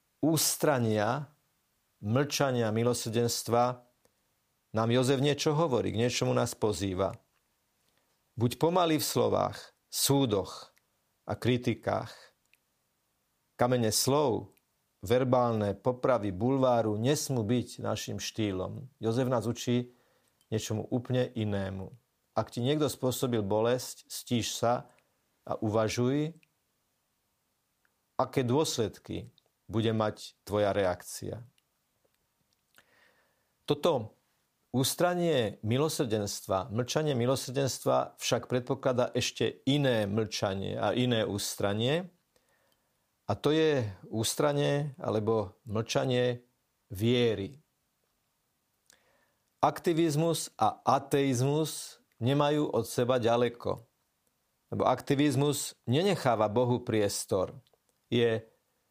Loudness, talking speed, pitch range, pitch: -30 LUFS, 85 wpm, 110-140 Hz, 120 Hz